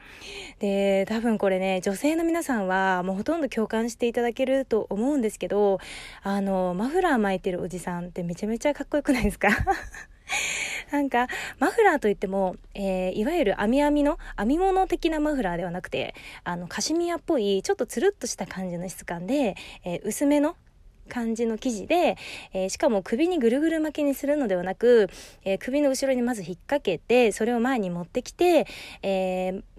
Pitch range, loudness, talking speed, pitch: 190-285 Hz, -25 LUFS, 385 characters per minute, 225 Hz